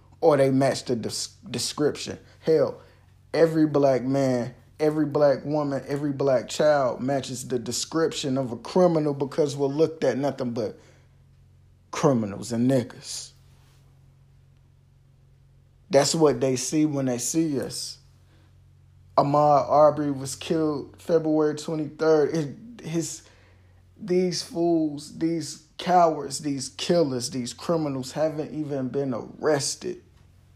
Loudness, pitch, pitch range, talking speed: -24 LUFS, 140 Hz, 130-155 Hz, 110 wpm